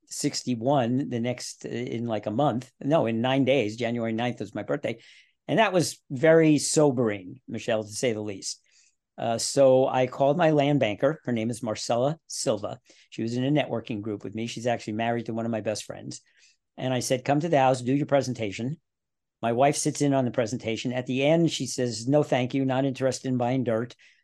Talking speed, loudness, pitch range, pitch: 210 wpm, -26 LUFS, 115-140 Hz, 125 Hz